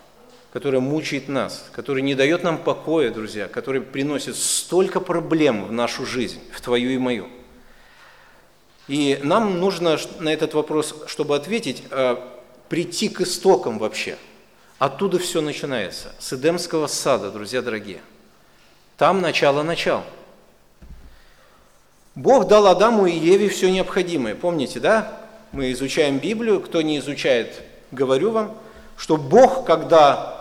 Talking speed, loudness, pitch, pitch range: 125 wpm, -20 LUFS, 160 Hz, 135-185 Hz